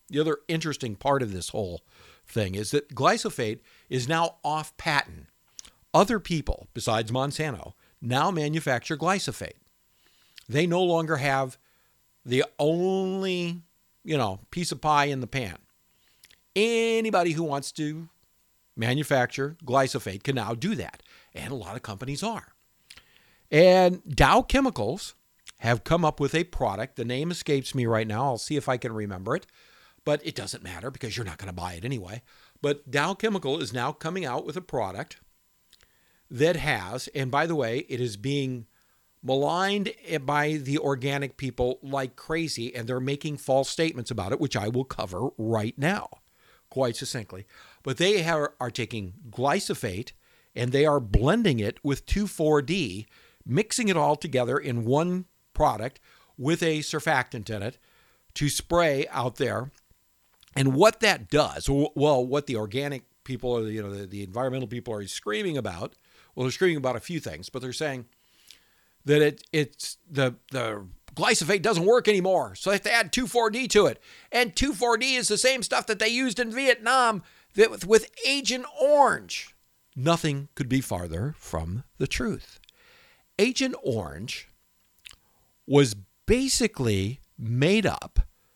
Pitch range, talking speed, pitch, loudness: 125-175 Hz, 155 wpm, 140 Hz, -26 LUFS